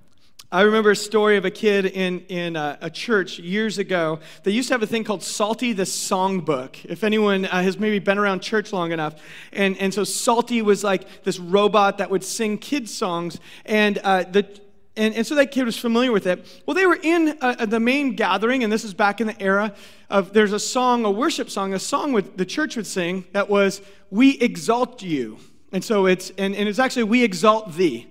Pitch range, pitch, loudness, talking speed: 190-225 Hz, 205 Hz, -21 LUFS, 220 wpm